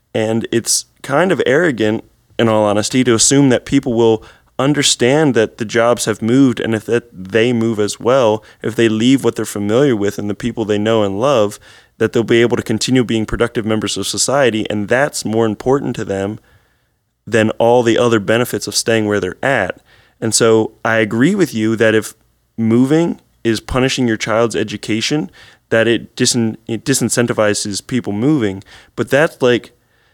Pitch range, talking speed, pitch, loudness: 110-120 Hz, 180 wpm, 115 Hz, -15 LUFS